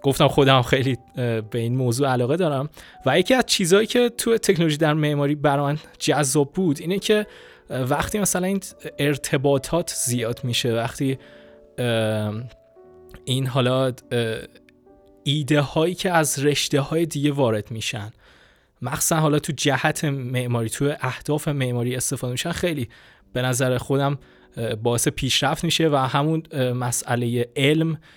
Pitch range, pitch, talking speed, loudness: 125-155 Hz, 140 Hz, 130 wpm, -22 LUFS